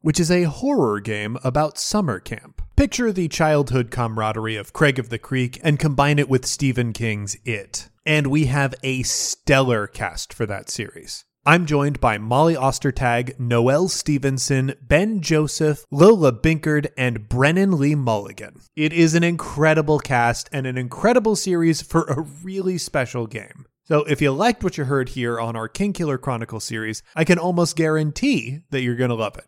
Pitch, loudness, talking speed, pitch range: 140 Hz, -20 LUFS, 175 wpm, 120-160 Hz